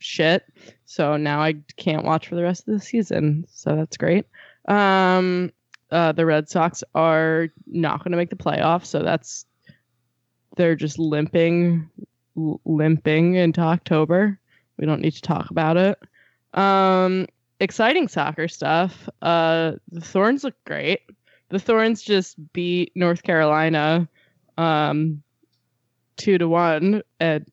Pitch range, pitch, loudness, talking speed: 155-180 Hz, 165 Hz, -21 LUFS, 135 wpm